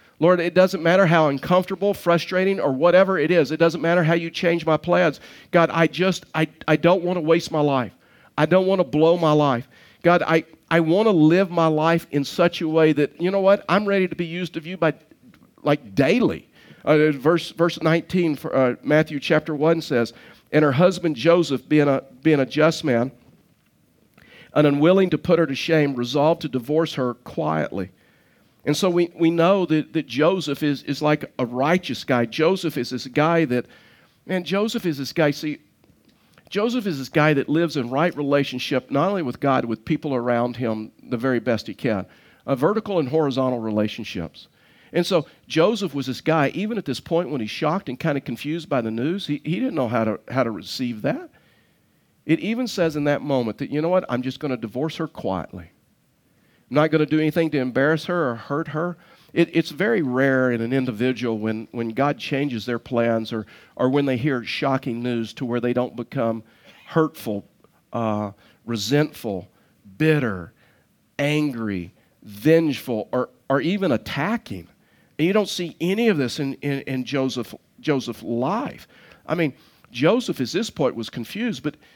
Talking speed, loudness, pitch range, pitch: 190 wpm, -22 LUFS, 130-170 Hz, 150 Hz